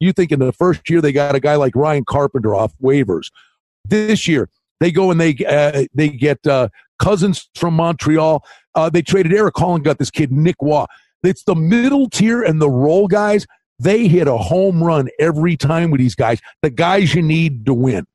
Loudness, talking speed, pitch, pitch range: -15 LUFS, 205 wpm, 160 Hz, 140-180 Hz